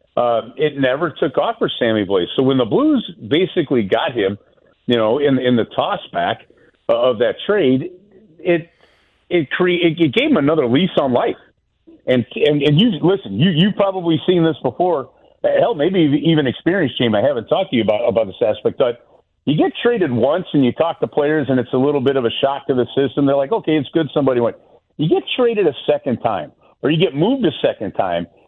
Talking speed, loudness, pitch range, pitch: 210 wpm, -17 LUFS, 130-180 Hz, 155 Hz